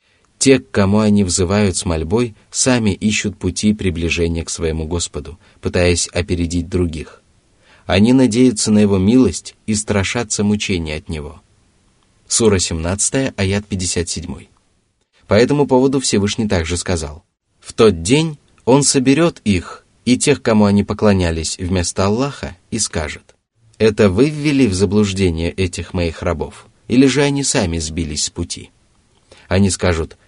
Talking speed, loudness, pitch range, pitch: 135 wpm, -16 LUFS, 90-110 Hz, 100 Hz